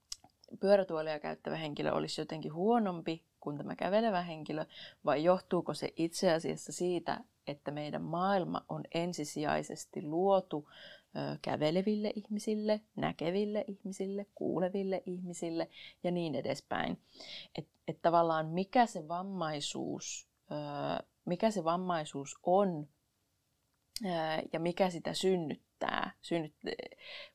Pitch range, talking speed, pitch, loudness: 155-195 Hz, 110 wpm, 175 Hz, -35 LUFS